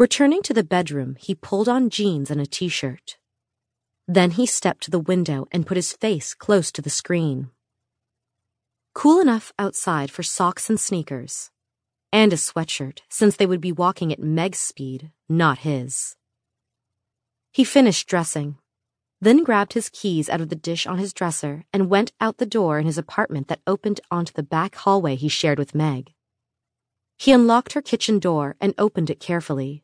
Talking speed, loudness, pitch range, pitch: 175 wpm, -21 LUFS, 135-200 Hz, 165 Hz